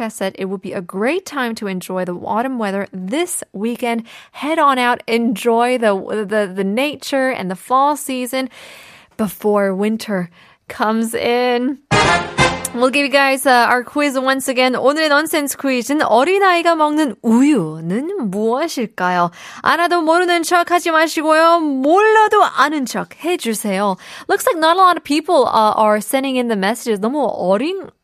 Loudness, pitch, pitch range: -16 LUFS, 255 Hz, 215-305 Hz